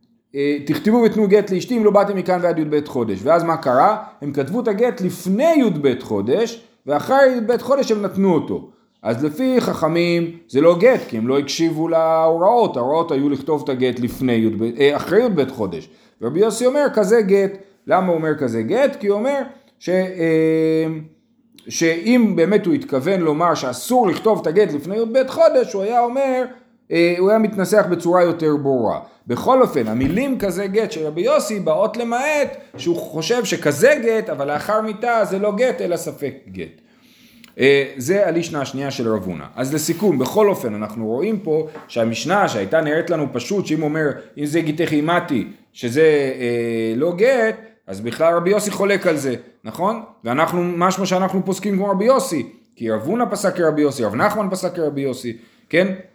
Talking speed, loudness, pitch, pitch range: 175 wpm, -18 LUFS, 175 Hz, 150-220 Hz